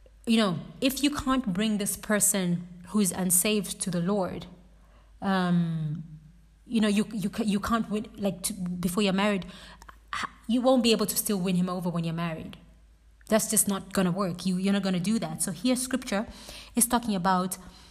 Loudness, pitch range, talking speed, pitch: -27 LUFS, 180-215 Hz, 220 wpm, 200 Hz